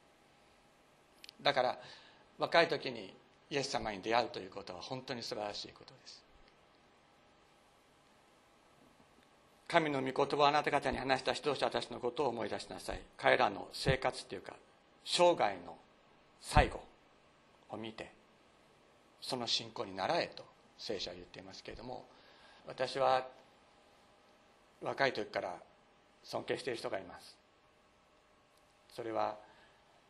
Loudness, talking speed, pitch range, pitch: -36 LUFS, 245 characters per minute, 105-135 Hz, 120 Hz